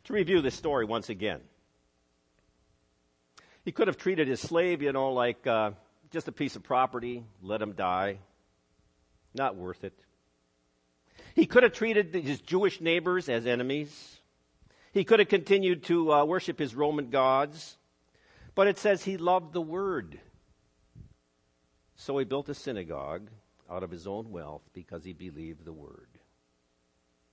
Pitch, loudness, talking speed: 110 Hz, -29 LUFS, 150 wpm